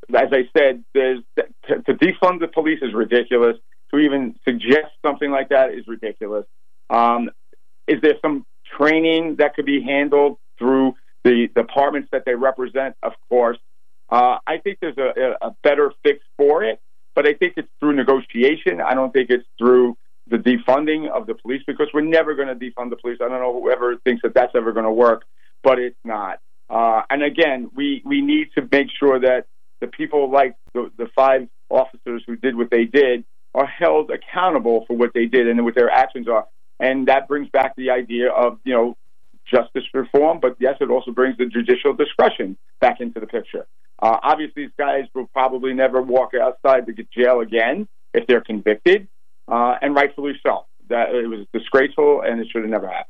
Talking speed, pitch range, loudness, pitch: 195 wpm, 120-150 Hz, -19 LUFS, 130 Hz